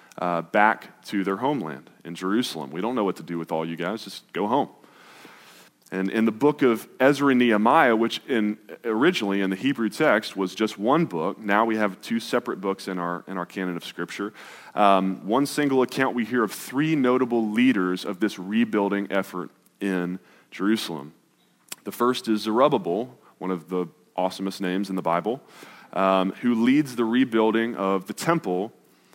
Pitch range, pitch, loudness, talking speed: 95-115 Hz, 100 Hz, -24 LUFS, 180 wpm